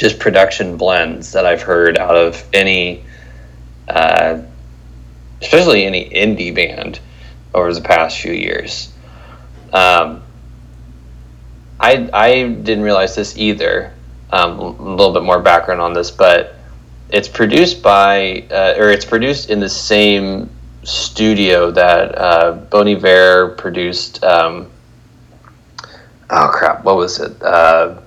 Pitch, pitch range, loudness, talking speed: 85 Hz, 60-100 Hz, -12 LUFS, 120 wpm